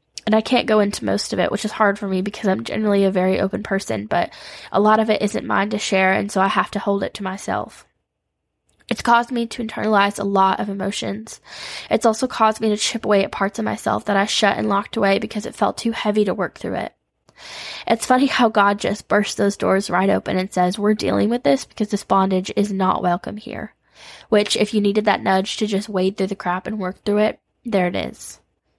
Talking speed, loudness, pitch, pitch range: 240 wpm, -20 LUFS, 205 Hz, 195-215 Hz